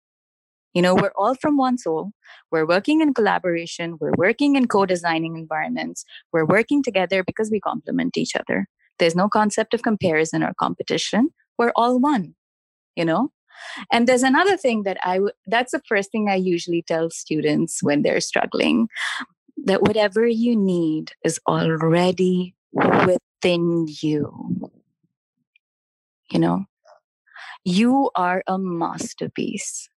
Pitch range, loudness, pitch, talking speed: 165-235 Hz, -21 LUFS, 190 Hz, 135 wpm